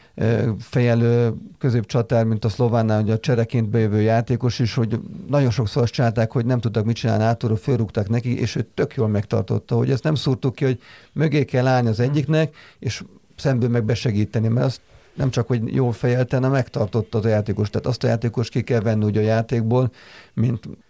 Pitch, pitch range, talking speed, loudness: 120 Hz, 115-130 Hz, 190 wpm, -21 LUFS